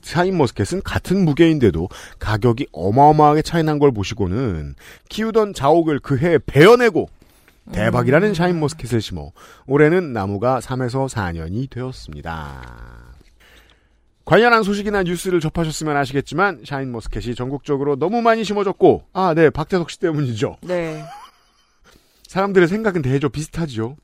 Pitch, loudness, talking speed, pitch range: 145 Hz, -18 LUFS, 335 characters per minute, 120-175 Hz